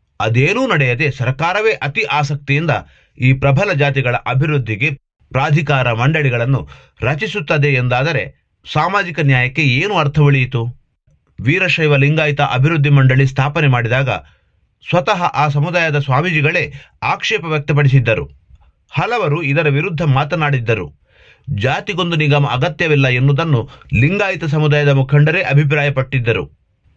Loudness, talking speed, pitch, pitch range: -15 LUFS, 95 wpm, 145 Hz, 130-150 Hz